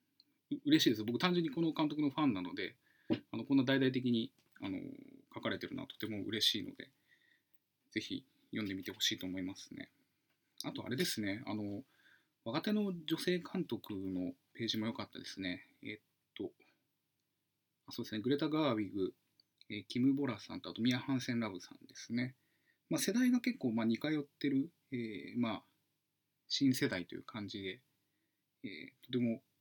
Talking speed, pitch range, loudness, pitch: 330 characters per minute, 110-155 Hz, -38 LUFS, 130 Hz